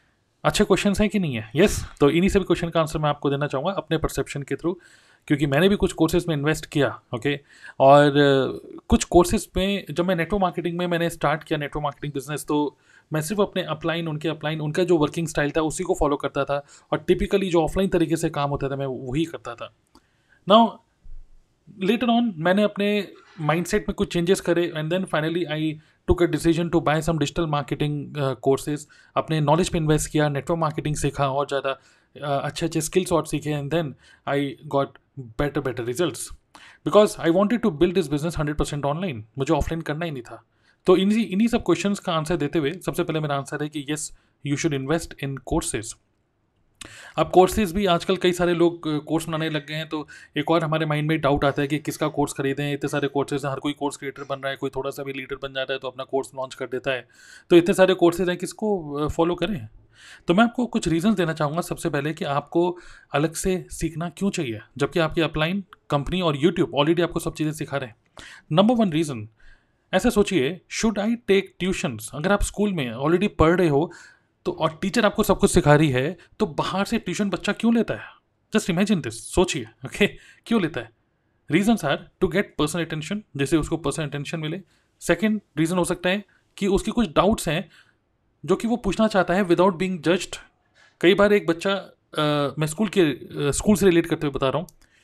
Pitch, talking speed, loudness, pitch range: 160 Hz, 215 wpm, -23 LUFS, 145-185 Hz